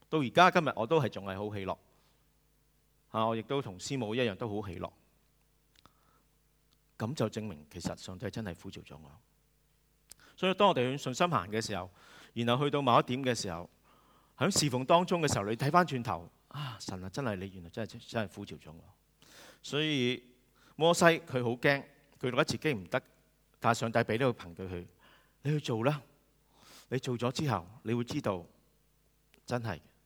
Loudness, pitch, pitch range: -32 LUFS, 125 Hz, 105-150 Hz